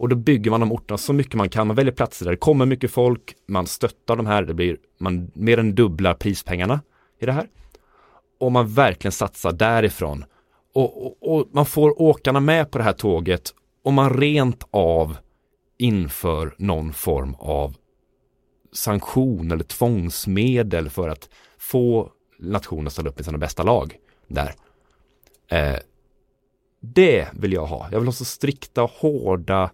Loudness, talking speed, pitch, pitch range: -21 LUFS, 165 wpm, 105 Hz, 85-125 Hz